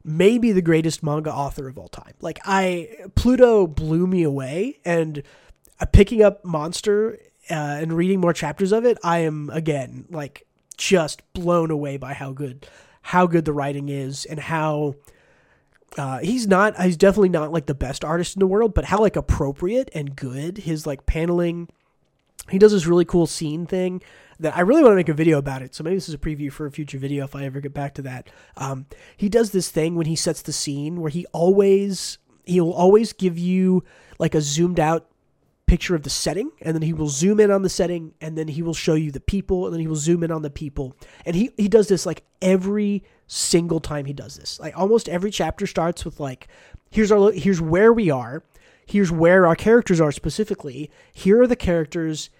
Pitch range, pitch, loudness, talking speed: 150-190 Hz, 165 Hz, -20 LUFS, 210 wpm